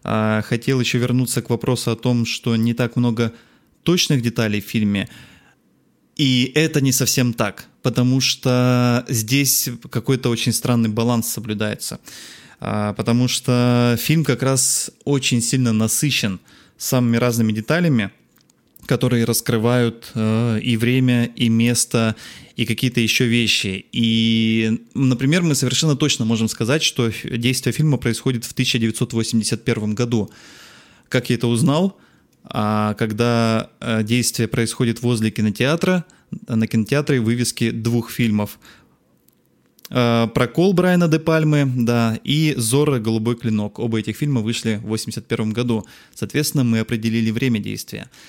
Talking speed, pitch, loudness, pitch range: 125 wpm, 120 Hz, -19 LUFS, 115-130 Hz